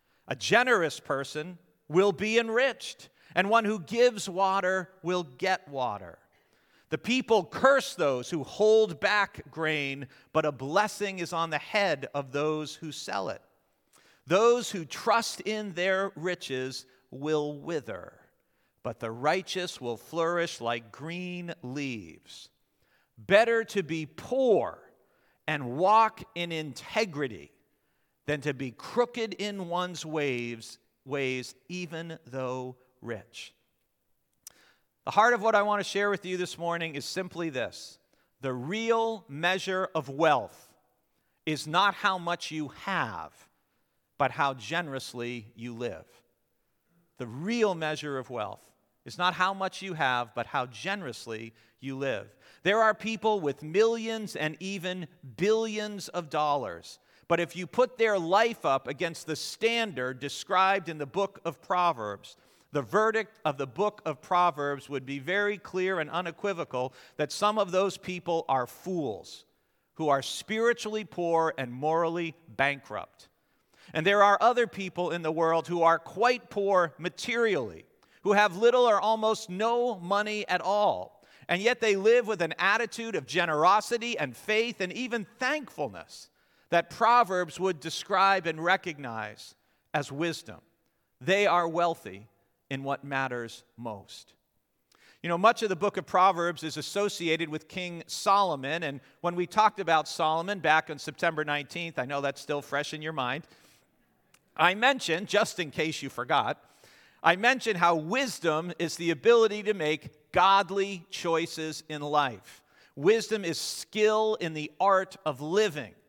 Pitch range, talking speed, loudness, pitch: 145-200 Hz, 145 wpm, -28 LUFS, 170 Hz